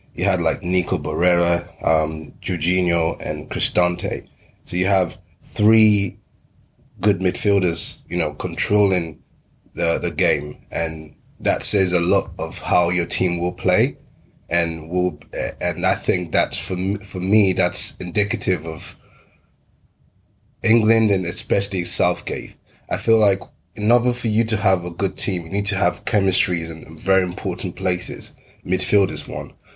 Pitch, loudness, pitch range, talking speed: 95 Hz, -19 LUFS, 90-105 Hz, 145 wpm